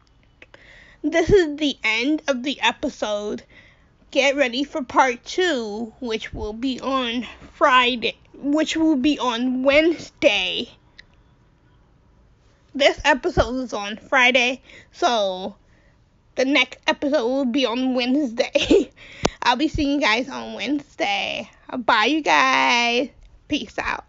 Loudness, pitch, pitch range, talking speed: -20 LUFS, 275 Hz, 245-300 Hz, 120 wpm